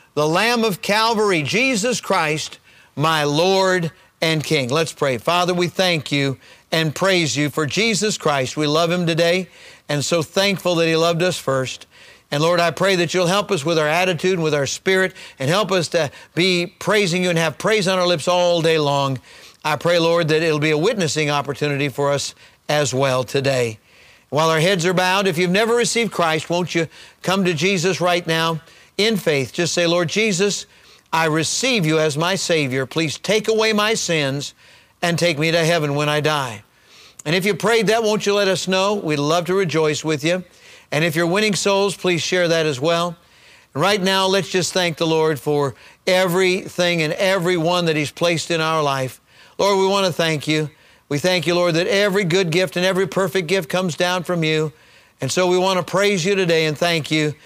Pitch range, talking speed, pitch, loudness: 155-190 Hz, 205 wpm, 170 Hz, -18 LUFS